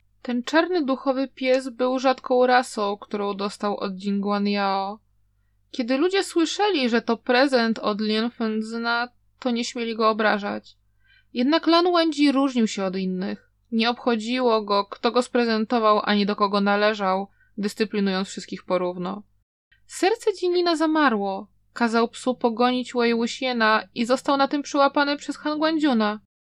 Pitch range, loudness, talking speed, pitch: 205-265 Hz, -23 LUFS, 135 wpm, 235 Hz